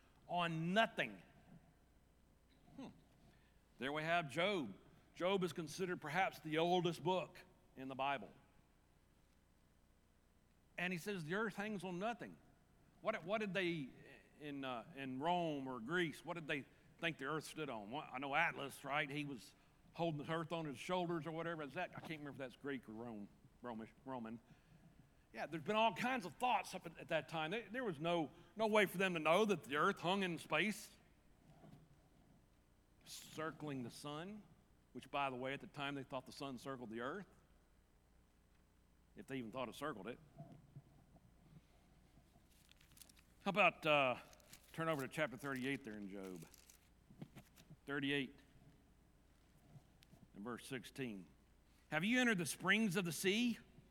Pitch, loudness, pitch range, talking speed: 150 Hz, -42 LUFS, 125-180 Hz, 160 wpm